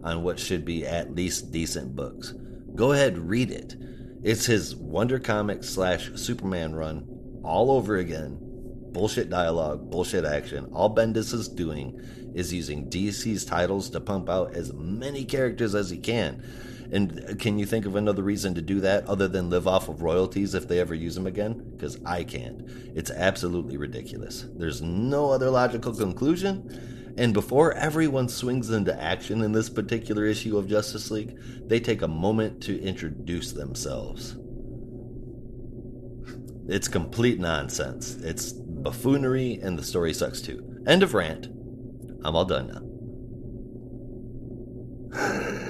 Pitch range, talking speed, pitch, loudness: 95-125 Hz, 150 wpm, 115 Hz, -27 LUFS